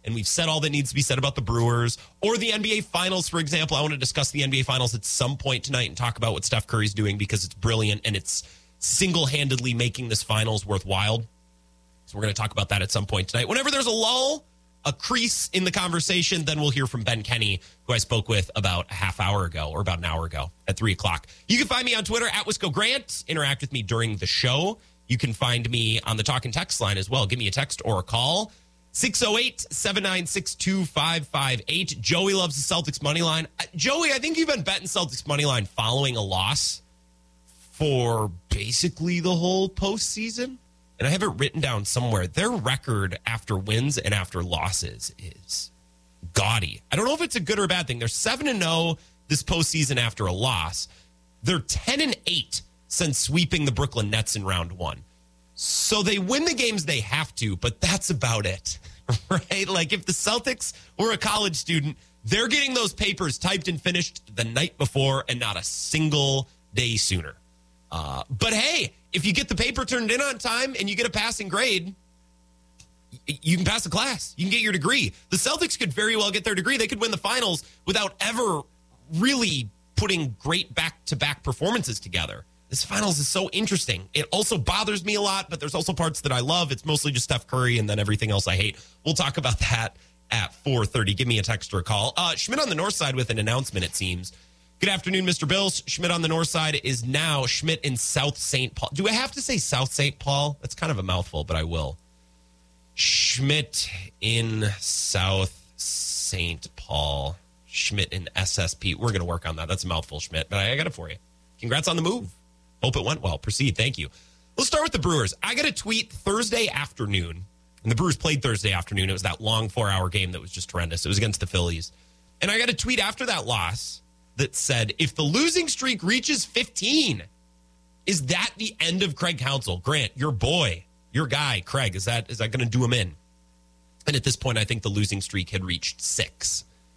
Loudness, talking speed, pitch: -24 LUFS, 210 wpm, 125 Hz